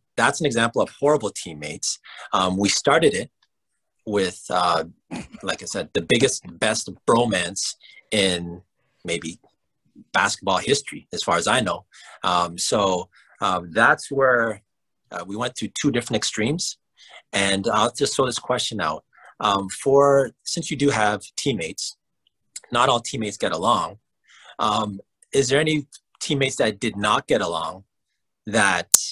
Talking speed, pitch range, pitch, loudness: 145 wpm, 95-140 Hz, 110 Hz, -22 LUFS